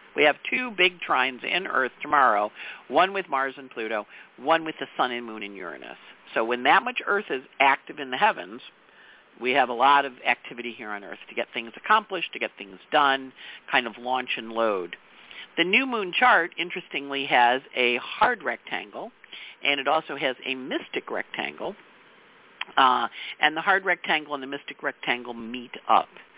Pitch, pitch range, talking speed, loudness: 135 Hz, 120-165 Hz, 180 wpm, -24 LUFS